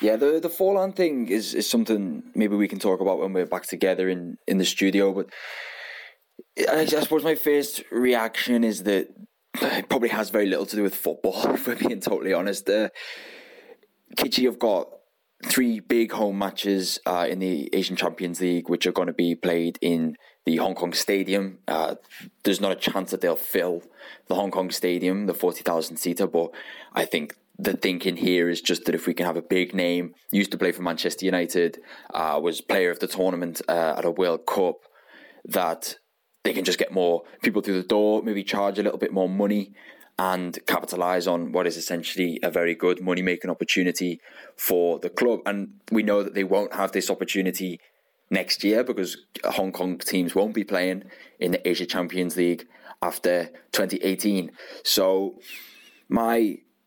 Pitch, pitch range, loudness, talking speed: 95 Hz, 90-105 Hz, -25 LUFS, 185 wpm